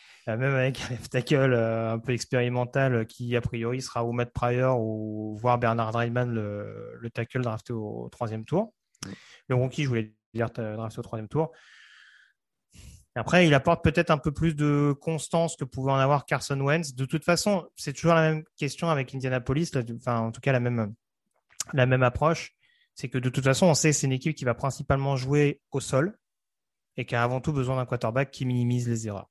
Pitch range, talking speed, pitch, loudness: 115-145 Hz, 205 wpm, 130 Hz, -27 LUFS